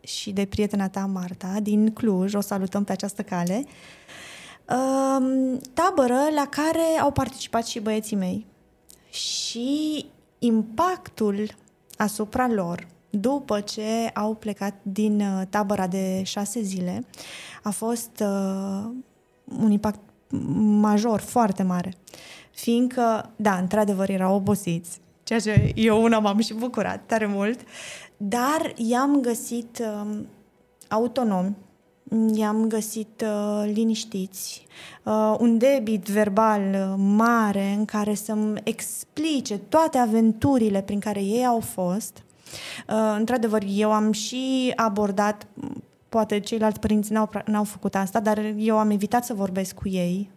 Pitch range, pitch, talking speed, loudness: 200-235 Hz, 215 Hz, 115 wpm, -24 LUFS